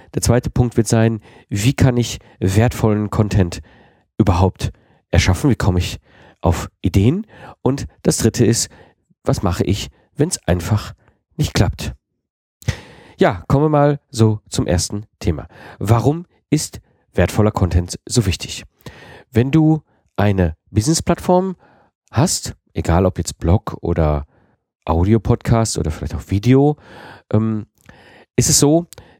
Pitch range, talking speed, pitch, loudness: 90-125 Hz, 125 wpm, 110 Hz, -18 LUFS